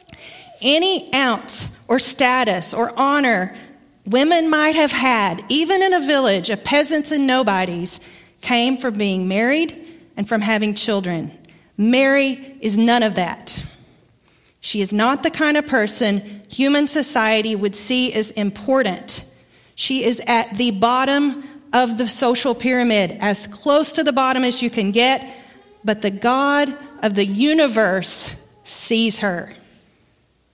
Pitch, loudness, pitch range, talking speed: 245 Hz, -18 LUFS, 210-275 Hz, 140 wpm